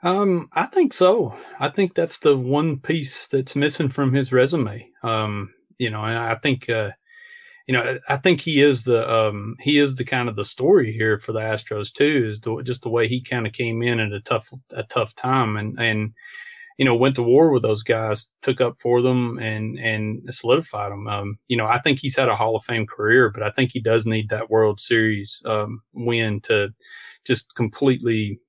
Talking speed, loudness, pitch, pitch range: 215 wpm, -21 LUFS, 120 Hz, 110-135 Hz